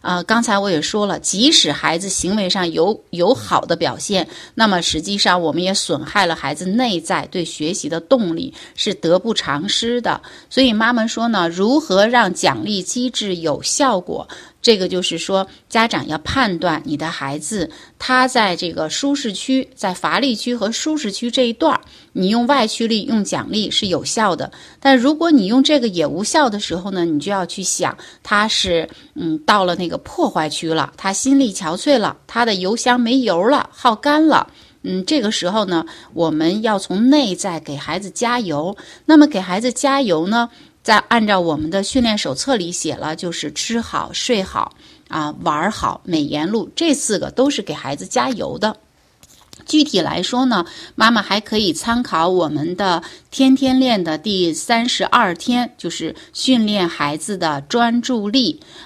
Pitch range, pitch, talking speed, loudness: 175-245 Hz, 210 Hz, 255 characters per minute, -17 LUFS